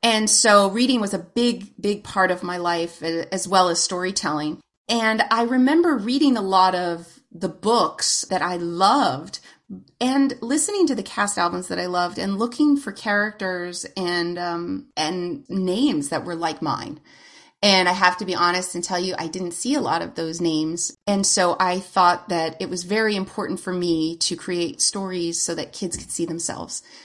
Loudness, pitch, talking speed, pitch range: -21 LUFS, 185 Hz, 190 wpm, 175-220 Hz